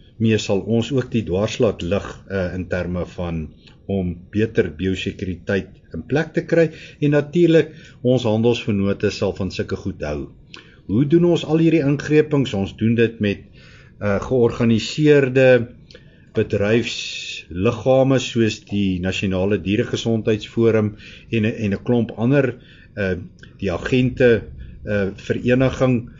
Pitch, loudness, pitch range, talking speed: 115 Hz, -20 LUFS, 100-130 Hz, 125 wpm